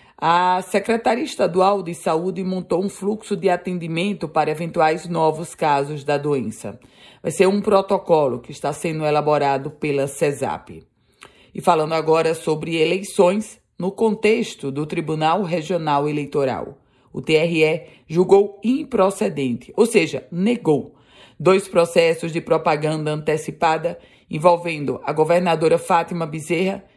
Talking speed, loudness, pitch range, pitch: 120 wpm, -20 LUFS, 155-185 Hz, 165 Hz